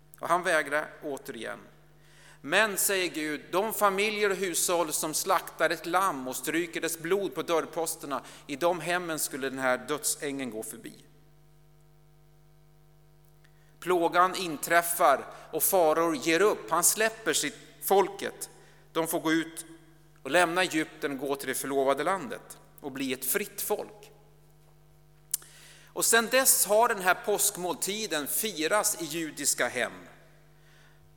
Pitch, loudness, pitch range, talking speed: 160 Hz, -27 LUFS, 155-180 Hz, 130 wpm